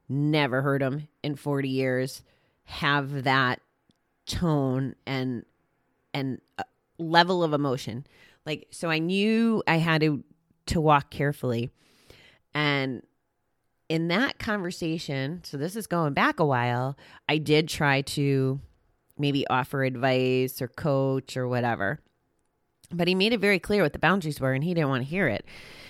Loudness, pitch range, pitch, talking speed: -26 LUFS, 130-160 Hz, 140 Hz, 145 wpm